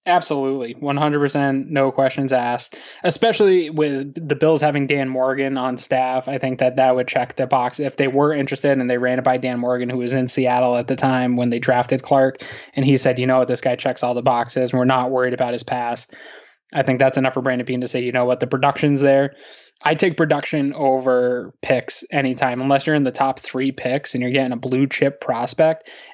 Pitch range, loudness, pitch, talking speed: 125-140 Hz, -19 LUFS, 130 Hz, 225 wpm